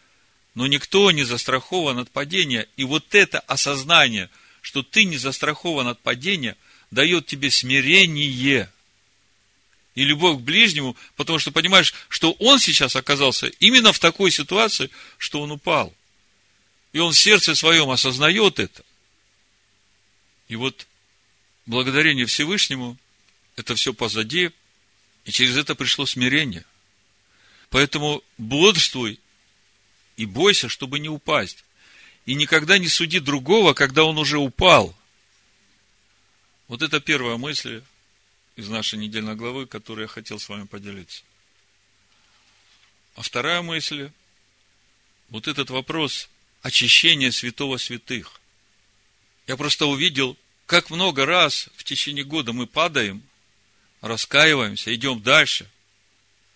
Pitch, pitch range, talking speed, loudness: 125 Hz, 105-150 Hz, 115 wpm, -18 LUFS